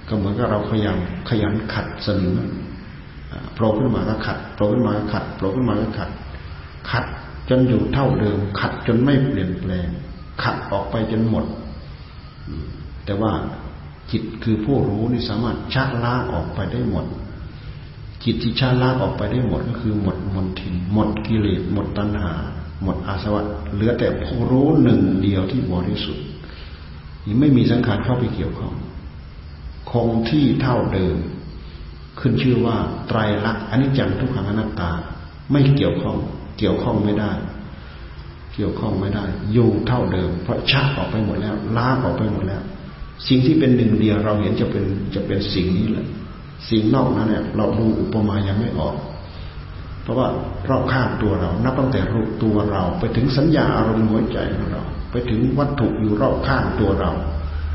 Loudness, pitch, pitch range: -20 LUFS, 105 Hz, 90-120 Hz